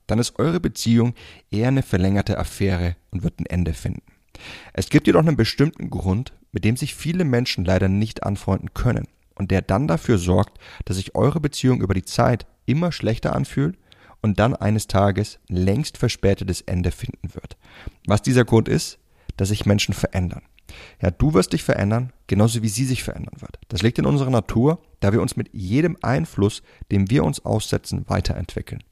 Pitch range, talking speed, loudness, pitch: 95-125 Hz, 180 wpm, -21 LUFS, 105 Hz